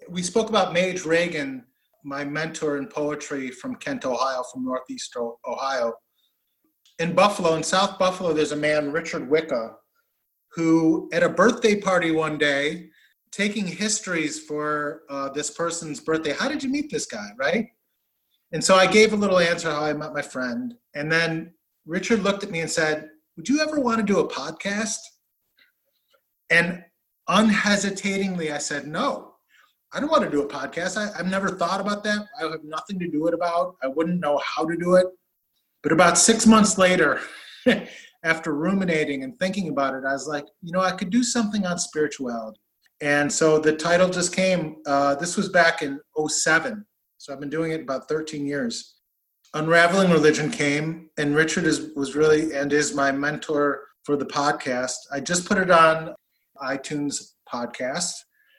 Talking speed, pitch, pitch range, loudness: 175 wpm, 165 Hz, 150-195 Hz, -23 LUFS